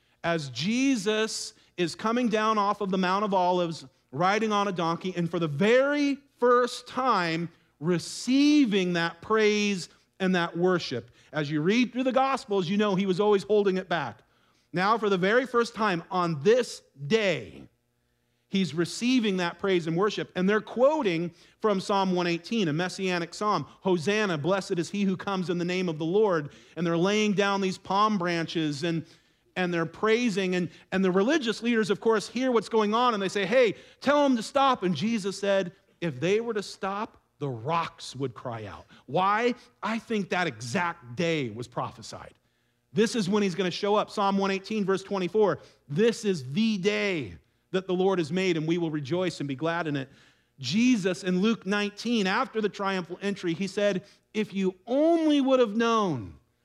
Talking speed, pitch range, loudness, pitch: 185 wpm, 170-215 Hz, -27 LUFS, 195 Hz